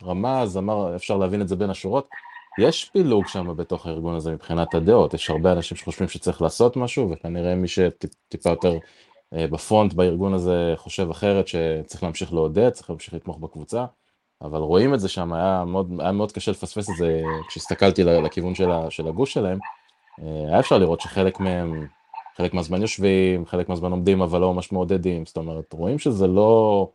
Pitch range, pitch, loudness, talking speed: 85-95 Hz, 90 Hz, -22 LUFS, 170 wpm